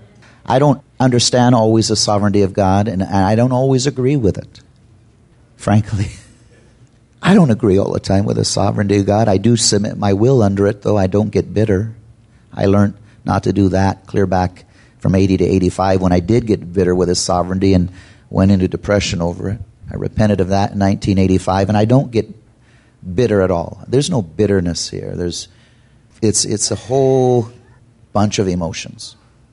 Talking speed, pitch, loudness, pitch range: 185 wpm, 105 Hz, -15 LUFS, 95-115 Hz